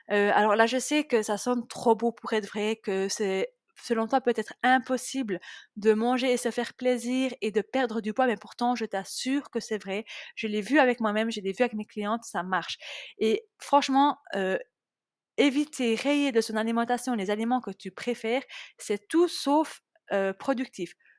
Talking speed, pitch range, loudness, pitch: 195 wpm, 210-260 Hz, -27 LUFS, 235 Hz